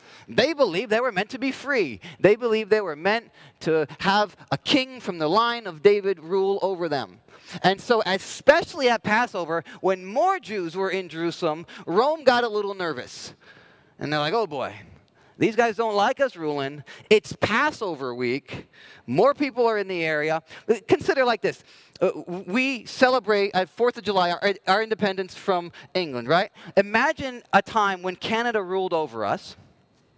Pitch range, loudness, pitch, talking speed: 170-235 Hz, -24 LUFS, 195 Hz, 165 wpm